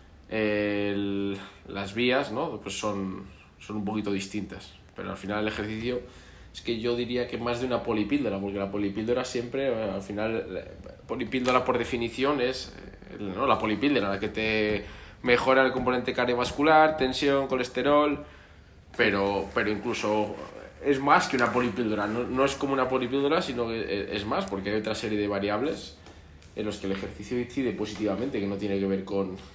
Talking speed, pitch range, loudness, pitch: 170 wpm, 100-125 Hz, -28 LUFS, 105 Hz